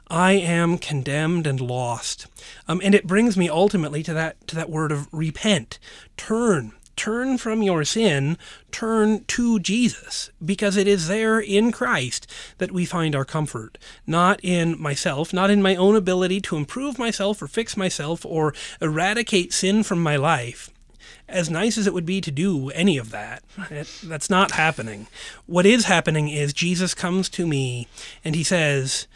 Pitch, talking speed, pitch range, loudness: 175 Hz, 170 wpm, 155-200 Hz, -21 LUFS